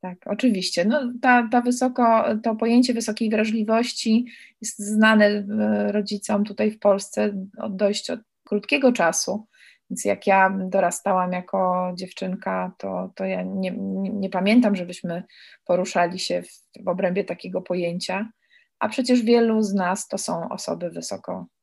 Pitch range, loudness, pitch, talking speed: 185-225 Hz, -22 LUFS, 205 Hz, 140 wpm